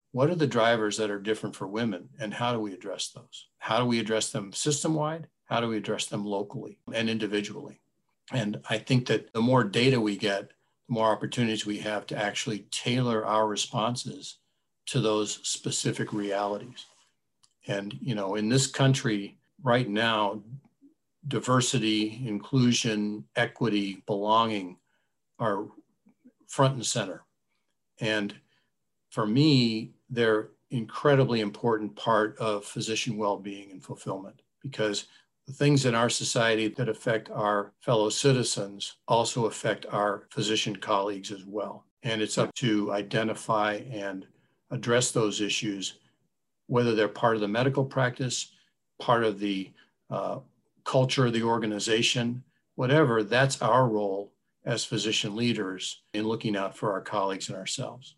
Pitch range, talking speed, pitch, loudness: 105-125 Hz, 140 wpm, 110 Hz, -28 LUFS